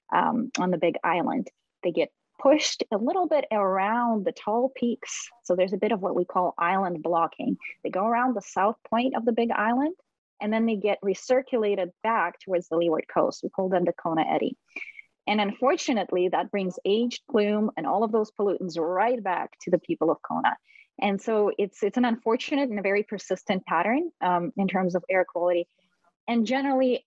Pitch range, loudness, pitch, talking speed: 185-245 Hz, -26 LUFS, 210 Hz, 195 wpm